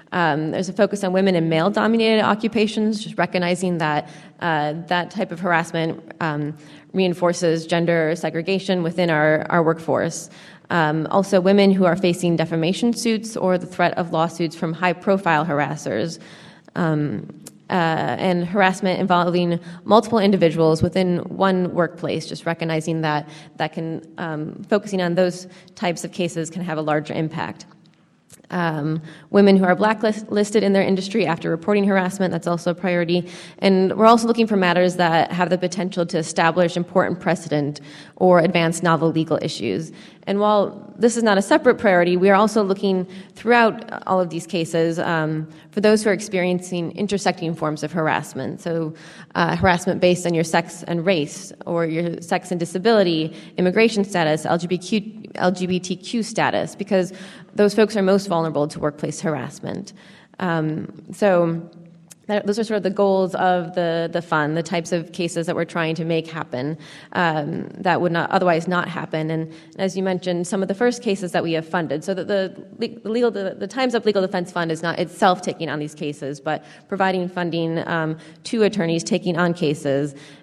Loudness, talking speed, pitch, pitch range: -20 LUFS, 170 wpm, 175 Hz, 165-195 Hz